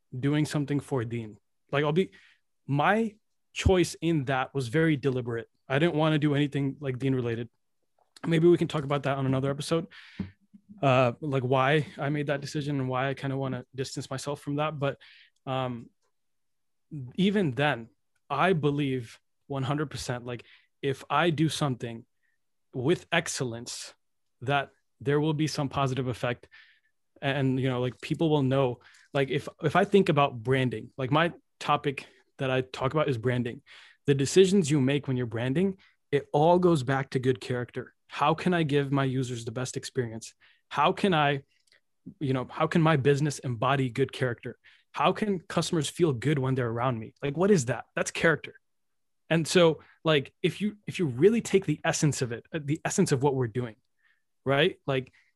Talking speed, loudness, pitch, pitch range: 180 wpm, -28 LUFS, 140 Hz, 130-155 Hz